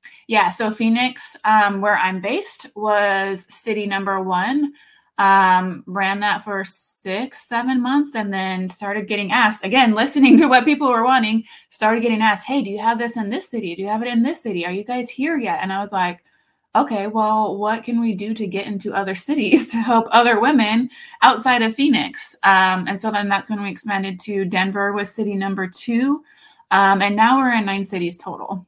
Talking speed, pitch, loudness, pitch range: 205 wpm, 215 Hz, -18 LUFS, 195-245 Hz